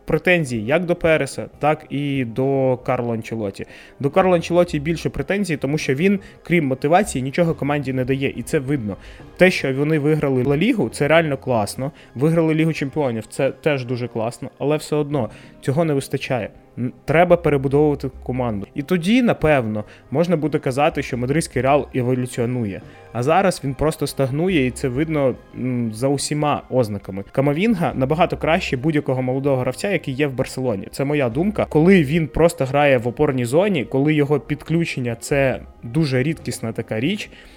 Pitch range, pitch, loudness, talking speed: 125-155 Hz, 140 Hz, -20 LUFS, 160 wpm